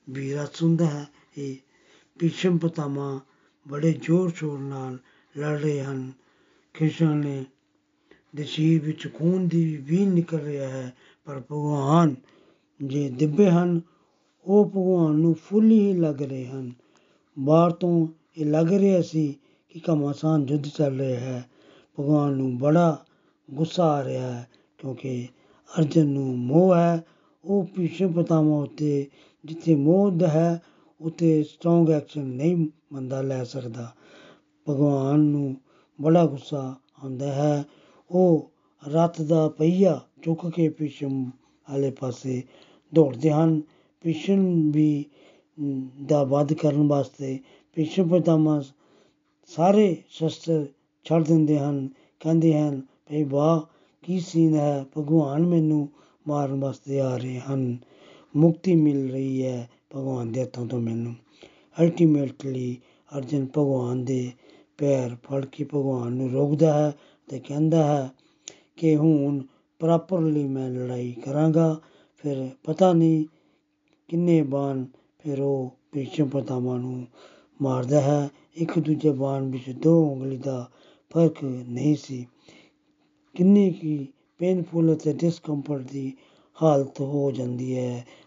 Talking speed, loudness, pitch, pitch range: 115 wpm, -24 LUFS, 150 Hz, 135-165 Hz